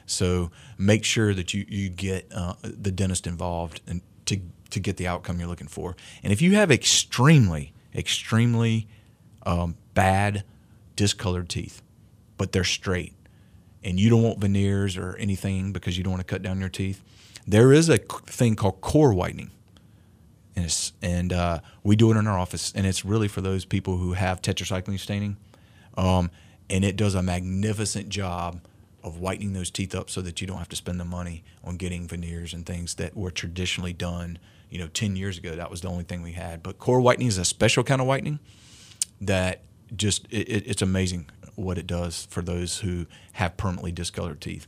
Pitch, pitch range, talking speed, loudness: 95 Hz, 90-105 Hz, 195 wpm, -25 LUFS